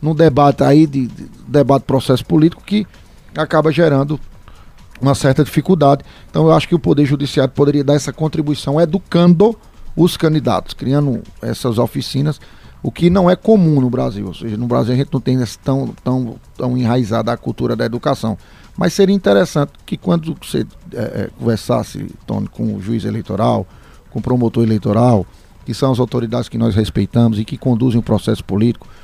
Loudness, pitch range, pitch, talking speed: -15 LUFS, 115-155 Hz, 135 Hz, 175 wpm